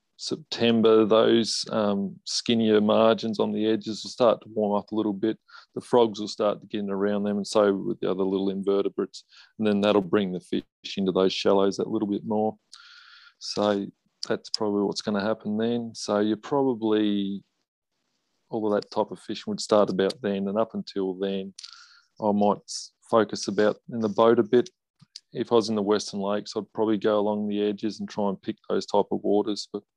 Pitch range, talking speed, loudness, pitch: 100-110 Hz, 200 wpm, -25 LUFS, 105 Hz